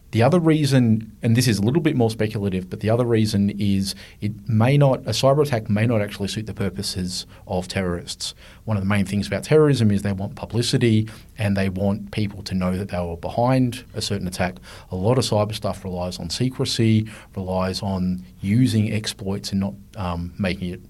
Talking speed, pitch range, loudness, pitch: 205 wpm, 95-115 Hz, -22 LUFS, 105 Hz